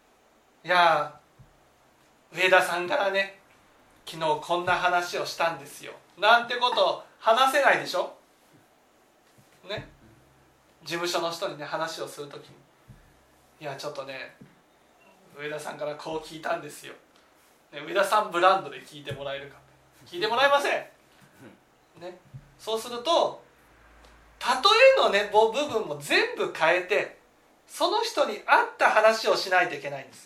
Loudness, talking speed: -24 LUFS, 275 characters per minute